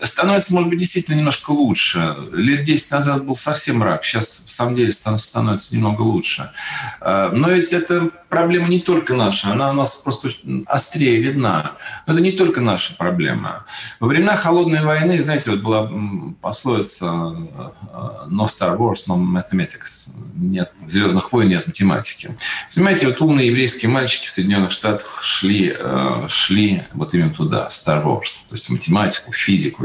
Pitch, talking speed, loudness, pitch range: 130 Hz, 155 wpm, -18 LUFS, 105-165 Hz